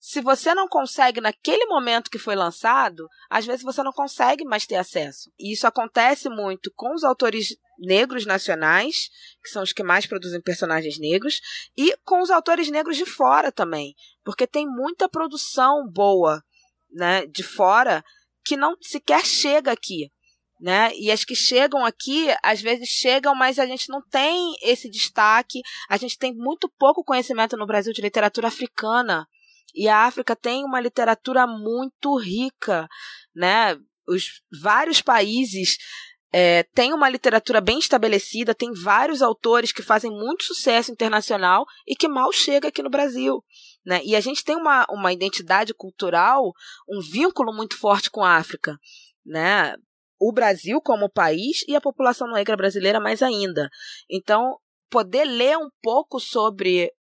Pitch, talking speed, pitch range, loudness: 240 Hz, 155 wpm, 205-280 Hz, -21 LUFS